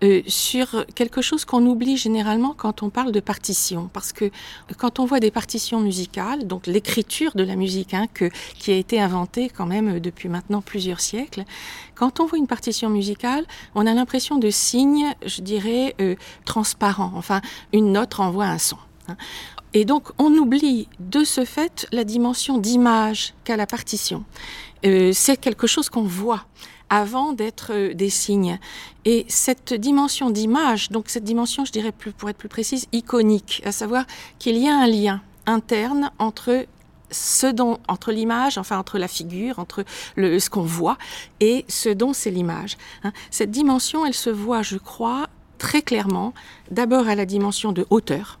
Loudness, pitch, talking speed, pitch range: -21 LUFS, 220 Hz, 170 wpm, 200-250 Hz